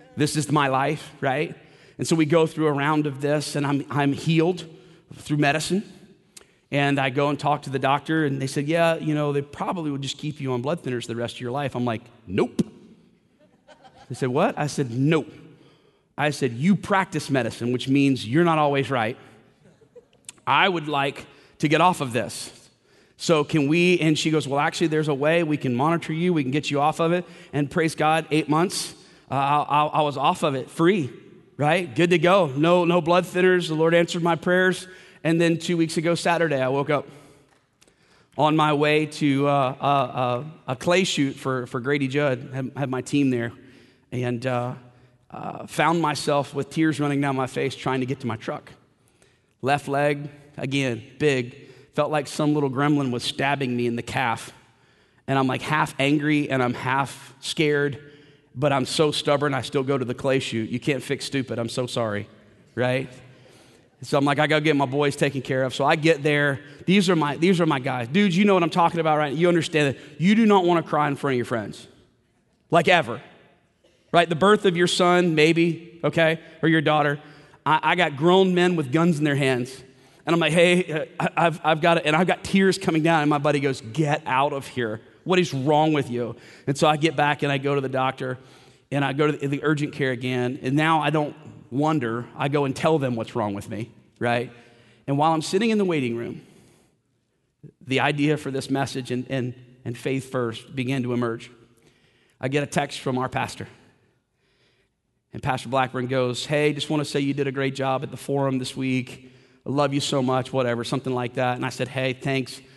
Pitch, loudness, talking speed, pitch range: 145 Hz, -23 LUFS, 215 wpm, 130-160 Hz